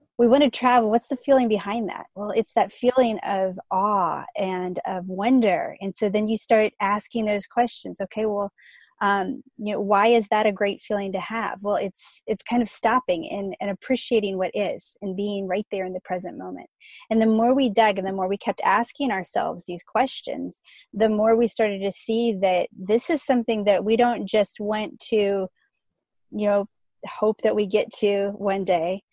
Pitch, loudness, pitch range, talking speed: 210 Hz, -23 LUFS, 195-230 Hz, 200 wpm